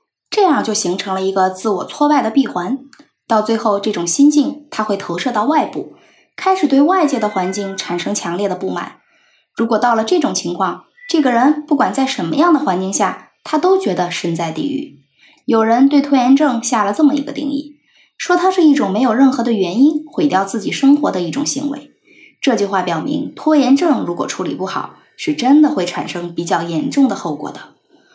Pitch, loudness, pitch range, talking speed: 260 Hz, -15 LUFS, 195-295 Hz, 295 characters per minute